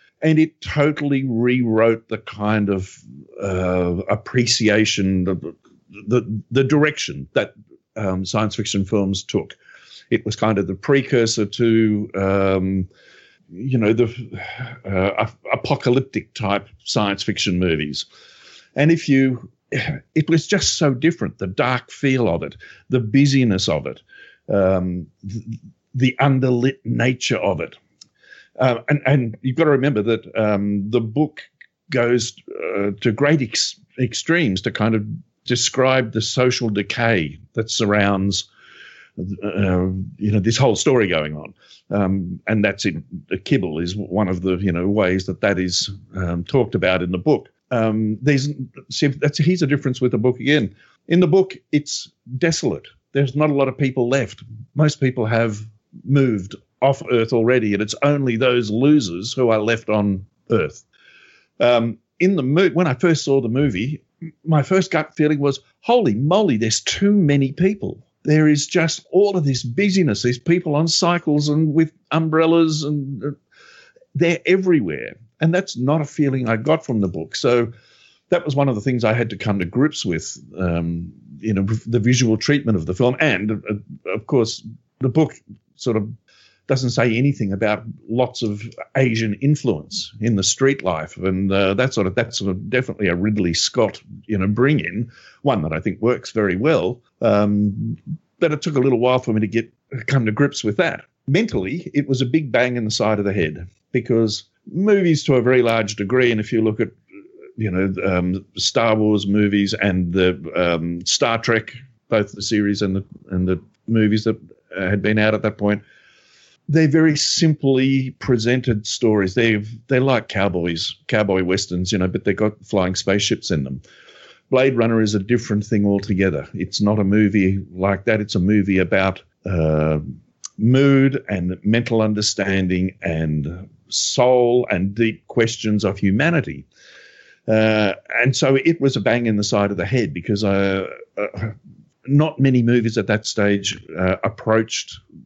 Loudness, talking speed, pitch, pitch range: -19 LUFS, 170 wpm, 115 Hz, 100-135 Hz